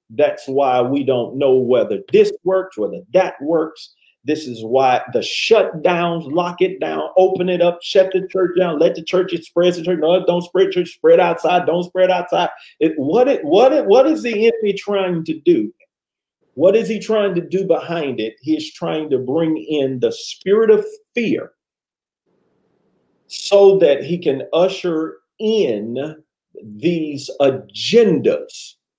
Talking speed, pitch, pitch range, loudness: 160 wpm, 180 Hz, 155-210 Hz, -17 LUFS